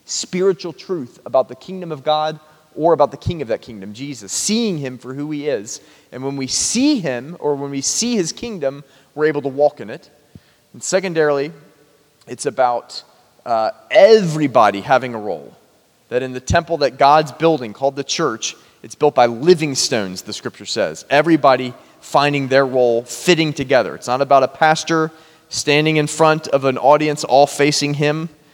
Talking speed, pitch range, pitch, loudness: 180 wpm, 130-160 Hz, 145 Hz, -17 LUFS